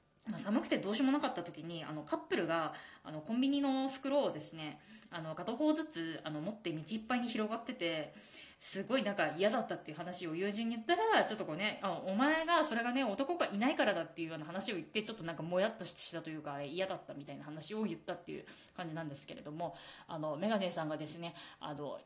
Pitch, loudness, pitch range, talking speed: 190 Hz, -36 LUFS, 165-250 Hz, 465 characters per minute